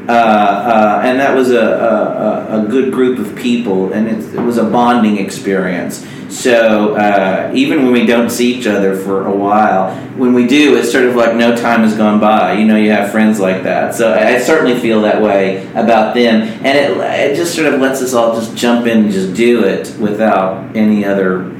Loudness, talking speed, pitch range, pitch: -11 LUFS, 215 wpm, 100-120 Hz, 110 Hz